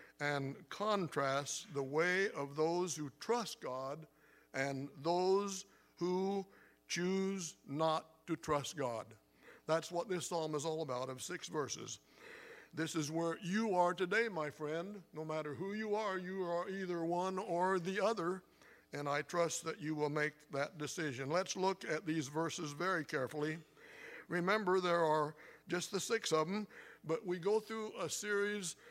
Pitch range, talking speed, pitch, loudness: 155-190 Hz, 160 wpm, 170 Hz, -38 LUFS